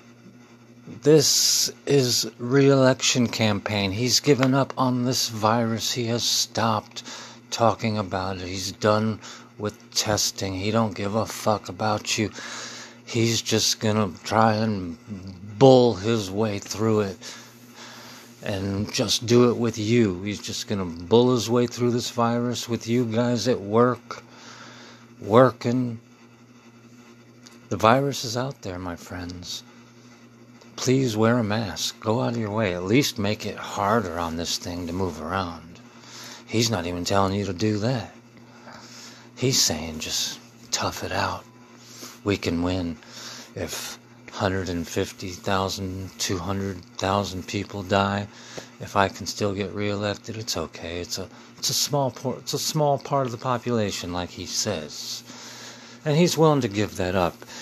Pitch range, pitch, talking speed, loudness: 100-120 Hz, 115 Hz, 145 wpm, -24 LUFS